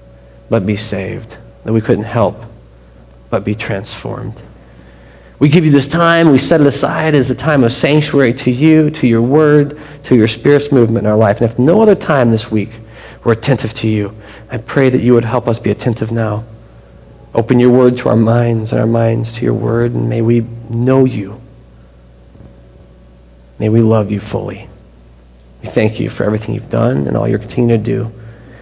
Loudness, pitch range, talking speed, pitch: -13 LUFS, 105-125 Hz, 195 wpm, 115 Hz